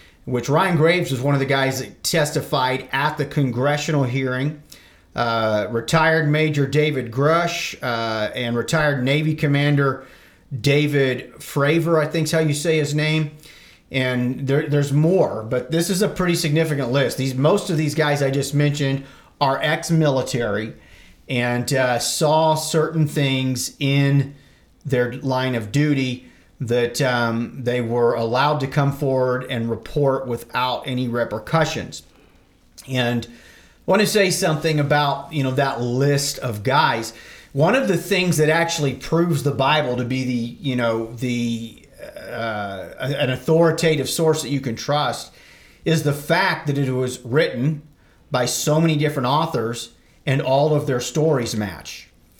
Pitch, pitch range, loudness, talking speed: 140 Hz, 125-155 Hz, -20 LUFS, 150 wpm